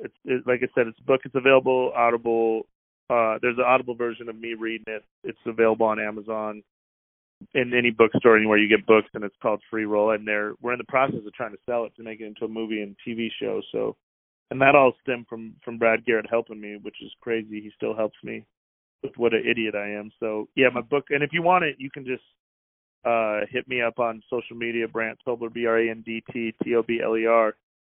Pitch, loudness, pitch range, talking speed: 115 Hz, -24 LUFS, 110-120 Hz, 245 wpm